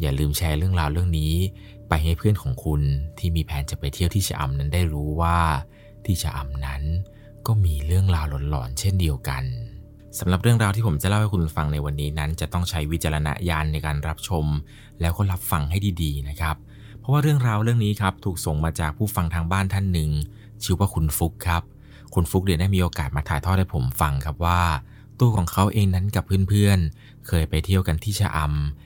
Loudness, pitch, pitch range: -23 LUFS, 85 Hz, 75-100 Hz